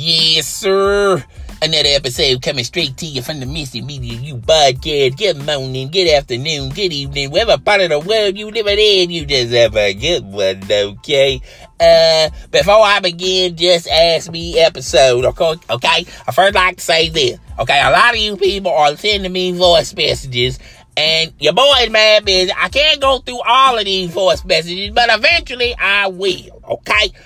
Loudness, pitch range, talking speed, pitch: -13 LUFS, 140-200 Hz, 180 wpm, 170 Hz